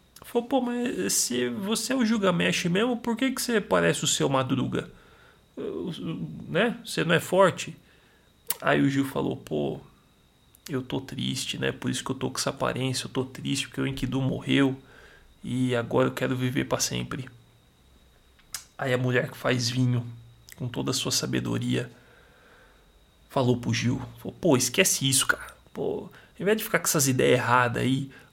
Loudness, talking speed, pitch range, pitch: -26 LUFS, 180 wpm, 120-185 Hz, 130 Hz